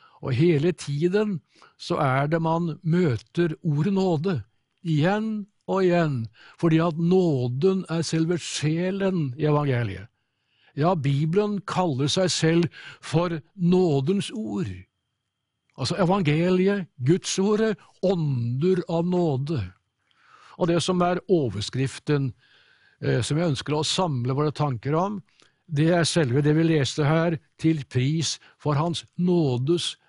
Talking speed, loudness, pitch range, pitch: 120 wpm, -24 LUFS, 135-180 Hz, 160 Hz